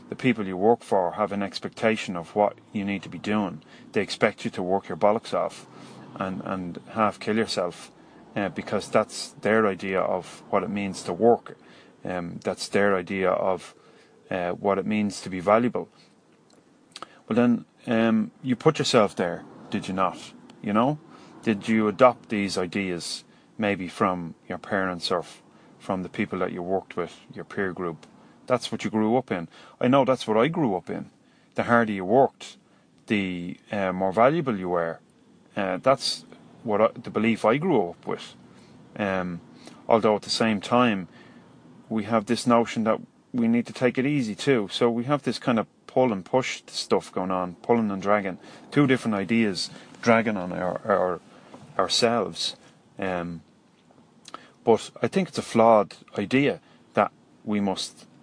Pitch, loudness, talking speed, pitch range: 105 Hz, -25 LUFS, 175 wpm, 95-120 Hz